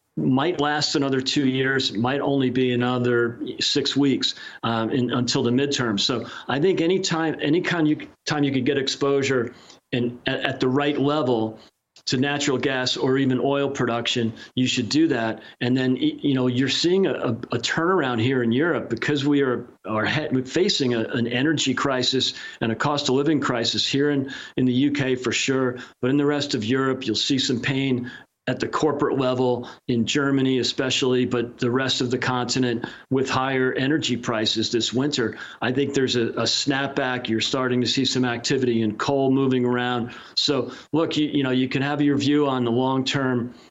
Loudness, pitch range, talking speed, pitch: -22 LUFS, 125-140 Hz, 195 wpm, 130 Hz